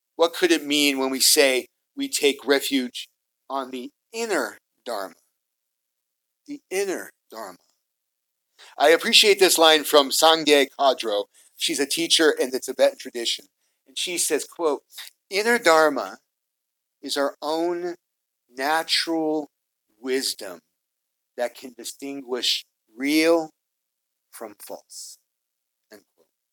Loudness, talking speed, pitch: -21 LUFS, 110 wpm, 140 Hz